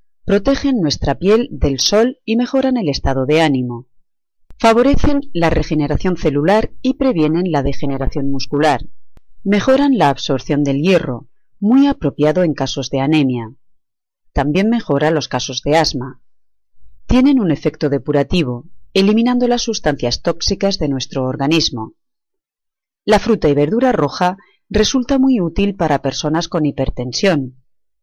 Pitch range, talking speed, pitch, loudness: 140-215 Hz, 130 wpm, 155 Hz, -16 LUFS